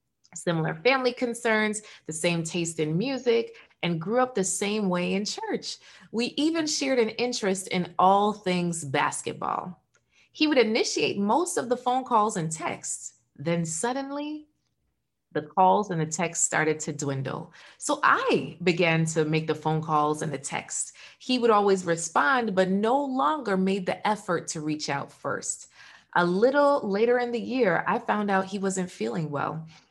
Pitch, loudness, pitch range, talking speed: 195 Hz, -26 LUFS, 165-245 Hz, 165 wpm